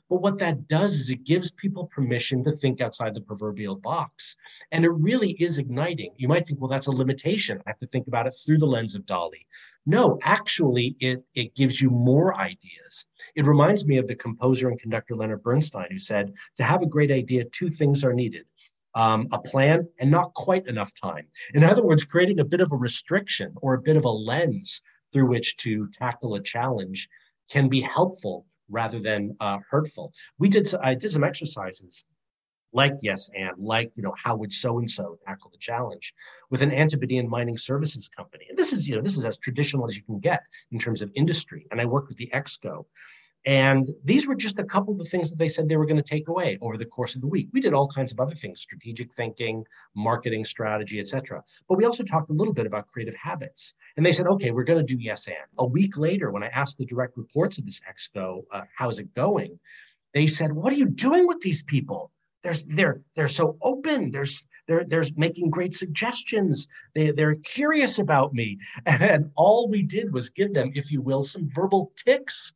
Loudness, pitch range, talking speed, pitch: -24 LUFS, 120-170 Hz, 215 wpm, 140 Hz